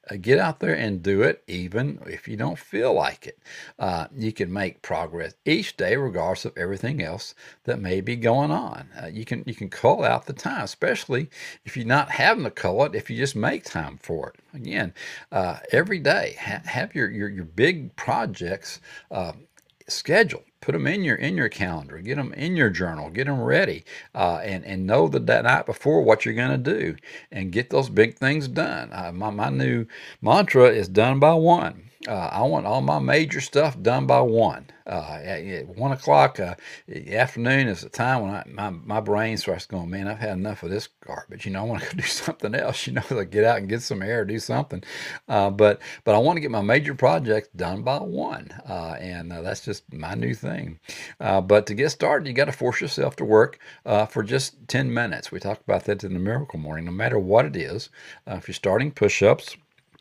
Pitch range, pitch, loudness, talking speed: 90-120 Hz, 105 Hz, -23 LUFS, 220 wpm